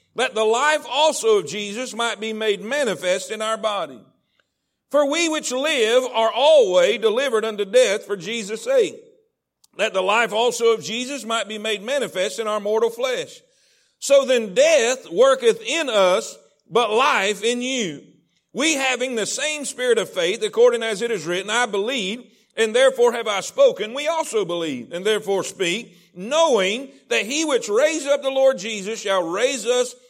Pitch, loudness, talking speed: 255 Hz, -20 LUFS, 170 wpm